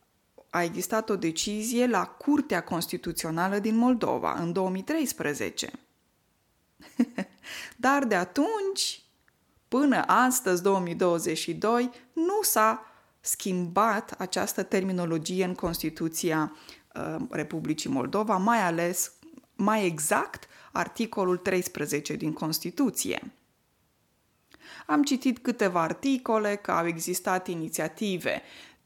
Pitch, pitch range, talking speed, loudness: 195 Hz, 175-240 Hz, 90 wpm, -28 LUFS